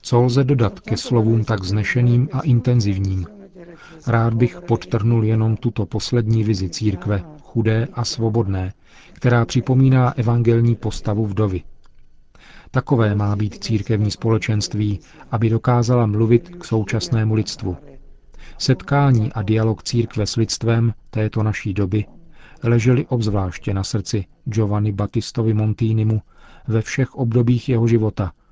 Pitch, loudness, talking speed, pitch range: 115 Hz, -19 LUFS, 120 wpm, 105-120 Hz